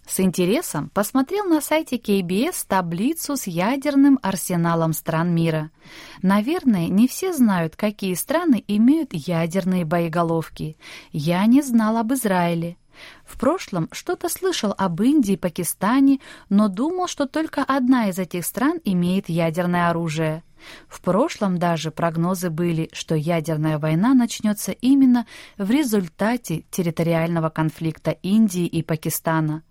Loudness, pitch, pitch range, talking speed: -21 LUFS, 190 Hz, 170-255 Hz, 125 wpm